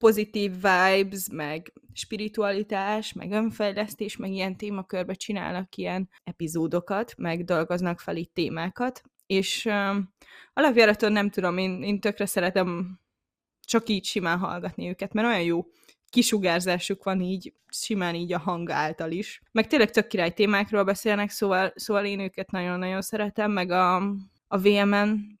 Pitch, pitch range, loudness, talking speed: 195 Hz, 180-210 Hz, -26 LUFS, 140 wpm